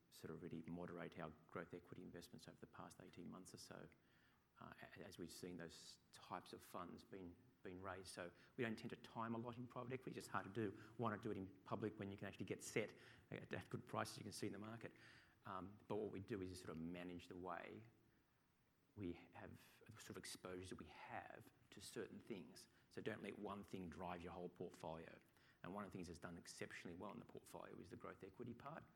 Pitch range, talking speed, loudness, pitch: 90-110 Hz, 230 wpm, -54 LUFS, 95 Hz